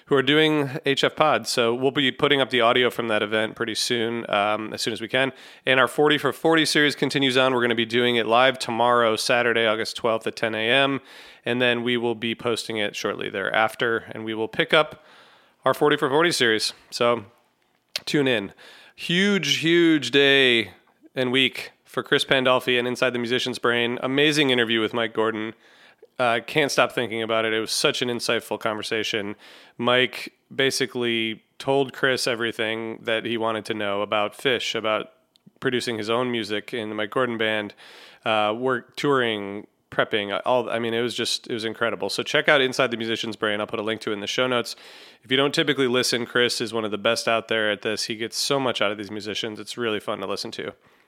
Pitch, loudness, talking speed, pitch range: 120 Hz, -22 LUFS, 210 wpm, 110-130 Hz